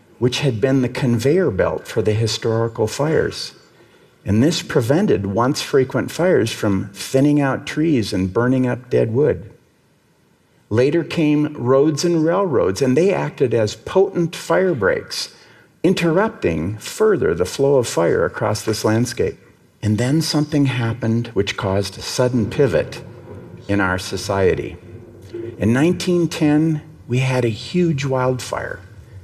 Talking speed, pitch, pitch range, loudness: 135 wpm, 130 Hz, 110-160 Hz, -19 LUFS